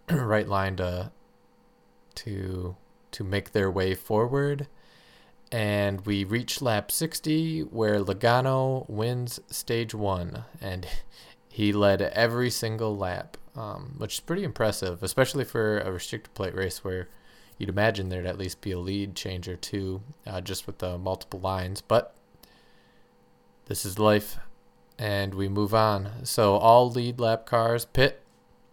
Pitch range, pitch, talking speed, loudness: 95-115 Hz, 105 Hz, 140 wpm, -27 LUFS